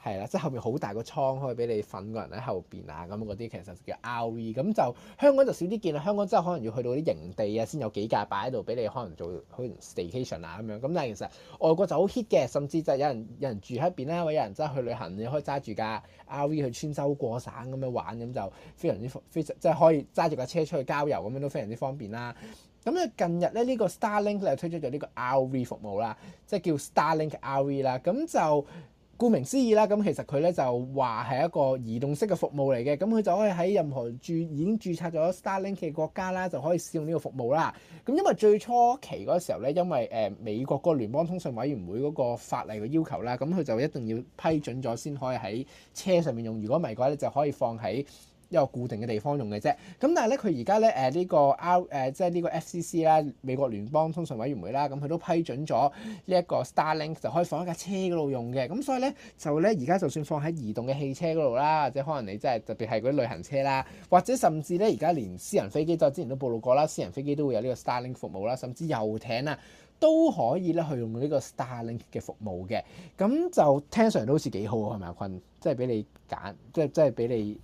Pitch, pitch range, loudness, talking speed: 145 Hz, 120-175 Hz, -29 LUFS, 395 characters per minute